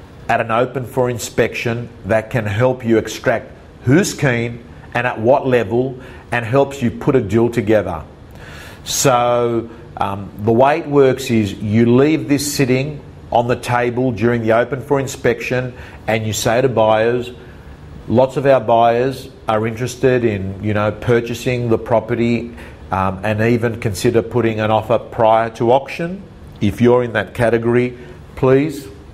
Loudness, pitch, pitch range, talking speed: -17 LUFS, 120 Hz, 110-130 Hz, 155 wpm